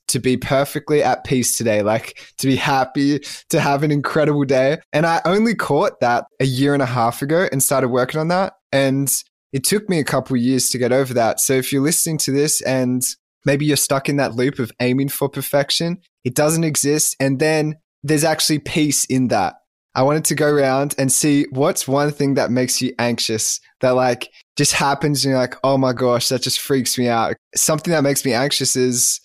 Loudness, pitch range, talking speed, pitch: -18 LUFS, 130-150 Hz, 215 wpm, 140 Hz